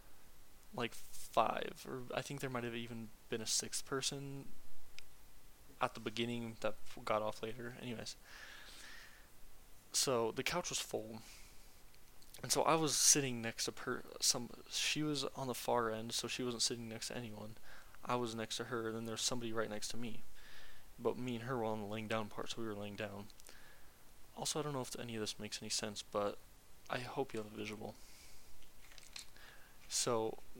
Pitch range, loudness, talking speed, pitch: 110-125 Hz, -39 LUFS, 185 wpm, 115 Hz